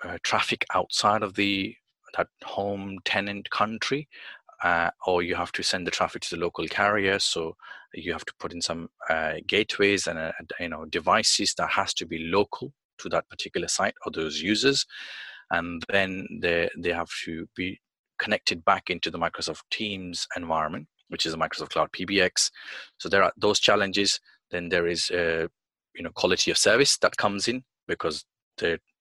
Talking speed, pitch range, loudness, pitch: 180 wpm, 85-100 Hz, -26 LUFS, 100 Hz